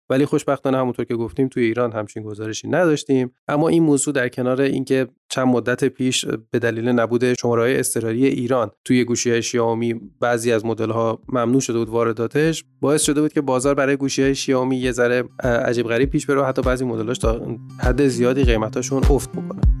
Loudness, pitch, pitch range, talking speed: -20 LUFS, 125 Hz, 115-135 Hz, 185 wpm